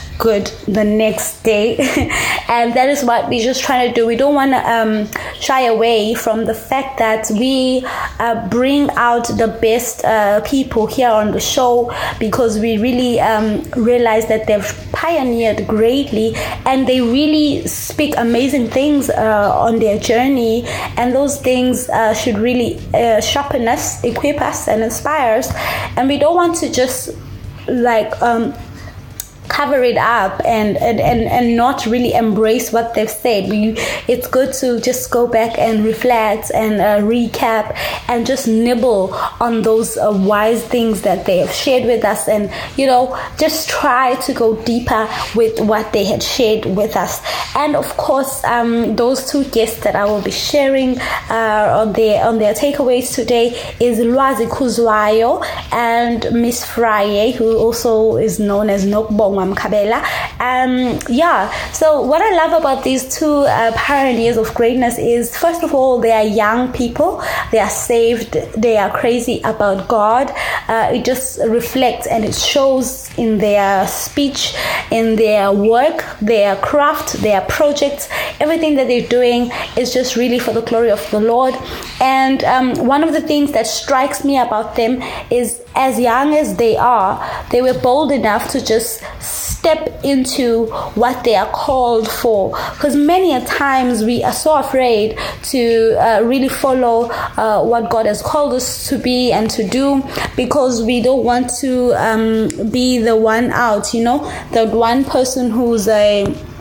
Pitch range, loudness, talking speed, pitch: 220-260 Hz, -14 LUFS, 165 wpm, 240 Hz